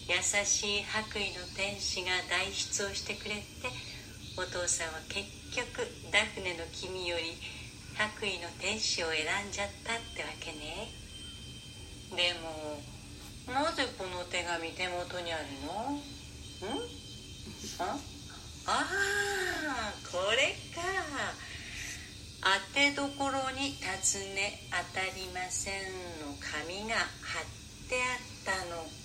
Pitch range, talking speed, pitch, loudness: 170-255 Hz, 200 characters per minute, 185 Hz, -34 LUFS